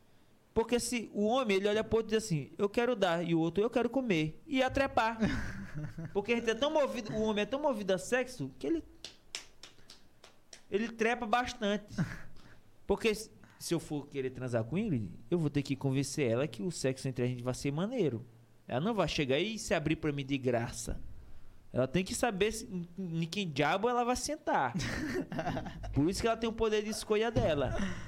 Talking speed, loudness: 210 wpm, -33 LUFS